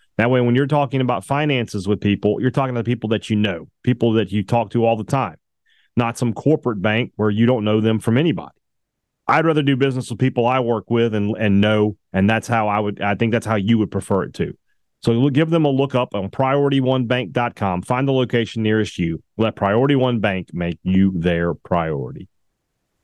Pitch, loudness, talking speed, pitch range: 115 Hz, -19 LUFS, 215 wpm, 105-130 Hz